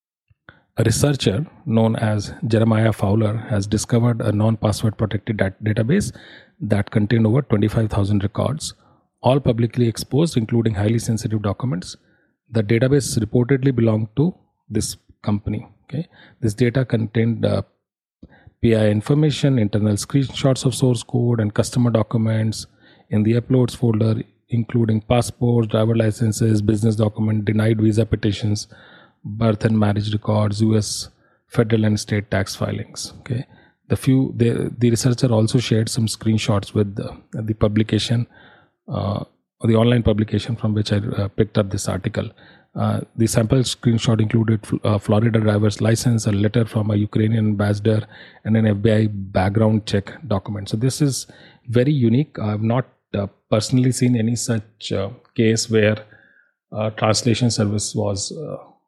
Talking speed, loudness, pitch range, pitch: 140 wpm, -20 LUFS, 105-120 Hz, 110 Hz